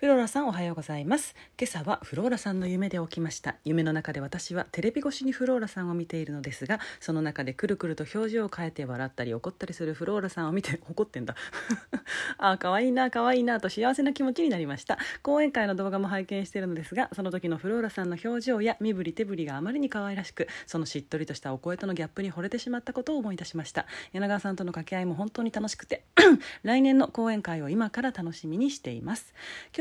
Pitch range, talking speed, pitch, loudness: 165-240 Hz, 500 characters per minute, 195 Hz, -29 LUFS